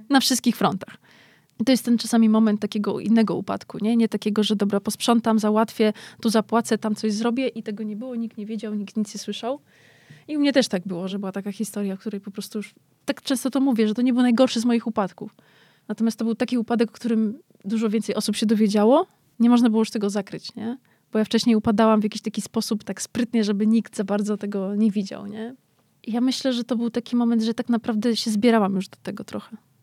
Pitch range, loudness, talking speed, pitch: 210-235 Hz, -23 LUFS, 235 wpm, 220 Hz